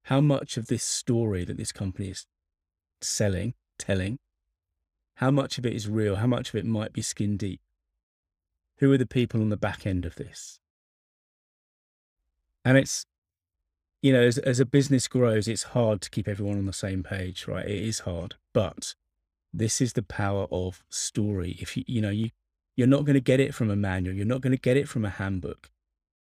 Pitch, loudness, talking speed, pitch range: 100 Hz, -27 LUFS, 200 wpm, 85-120 Hz